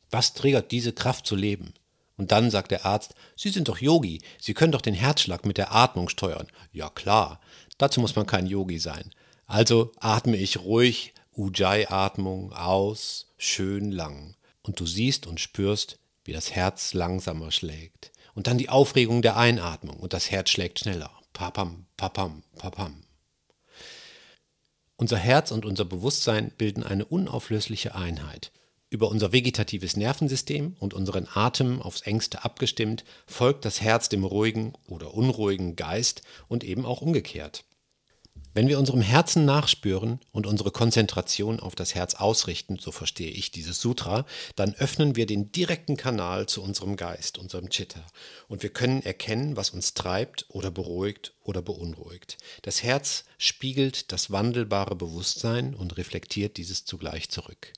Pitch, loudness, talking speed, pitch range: 105 Hz, -26 LUFS, 150 wpm, 95-120 Hz